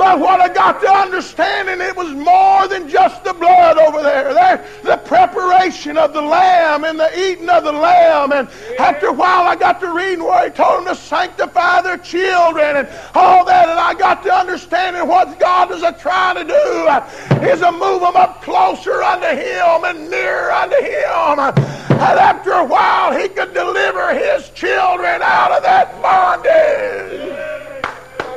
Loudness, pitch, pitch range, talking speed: -13 LUFS, 360 Hz, 335-370 Hz, 175 wpm